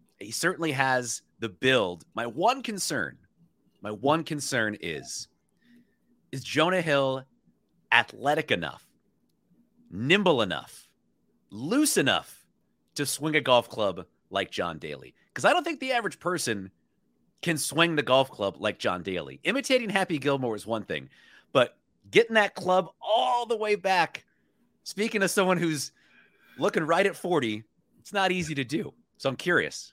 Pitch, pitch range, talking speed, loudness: 160 Hz, 130-200 Hz, 150 wpm, -27 LUFS